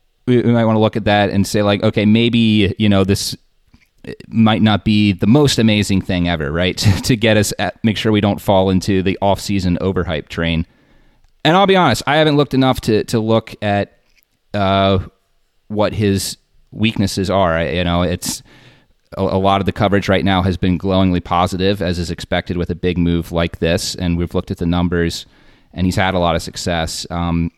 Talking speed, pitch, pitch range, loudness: 205 wpm, 95 Hz, 90-110 Hz, -16 LUFS